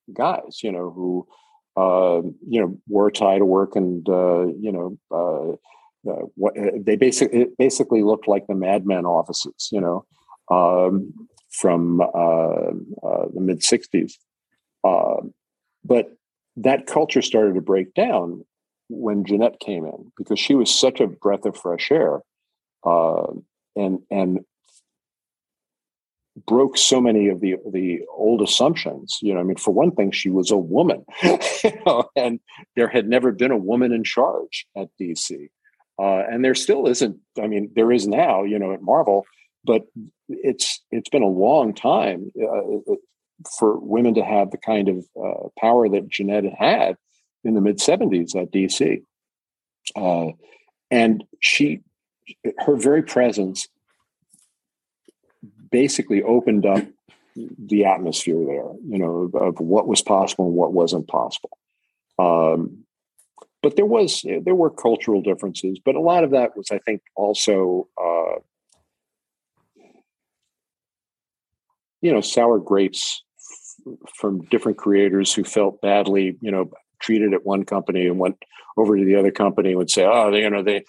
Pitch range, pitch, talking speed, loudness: 95-115 Hz, 100 Hz, 155 wpm, -20 LUFS